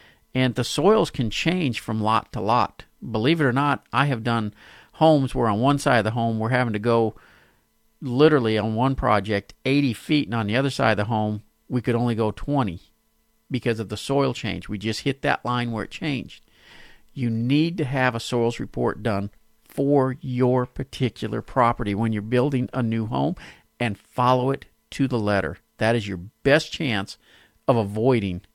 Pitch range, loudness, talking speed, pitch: 110-135 Hz, -23 LUFS, 190 wpm, 120 Hz